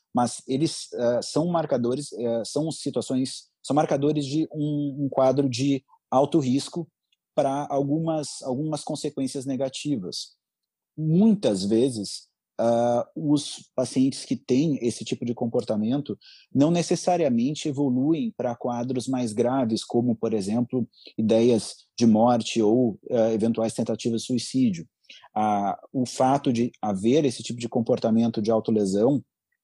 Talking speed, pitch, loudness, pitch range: 130 wpm, 130 Hz, -25 LUFS, 115-145 Hz